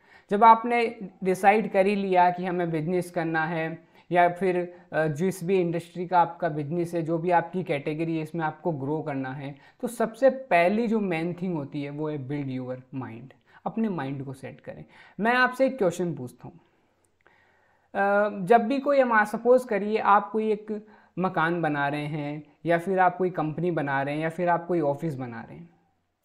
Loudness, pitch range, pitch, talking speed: -25 LUFS, 155-200 Hz, 175 Hz, 185 wpm